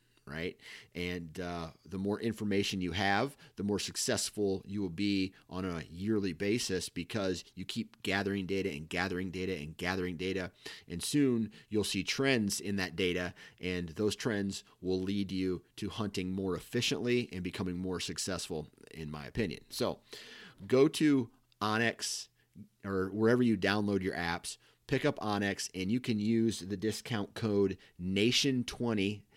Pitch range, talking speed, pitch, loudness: 90-105 Hz, 155 wpm, 100 Hz, -34 LUFS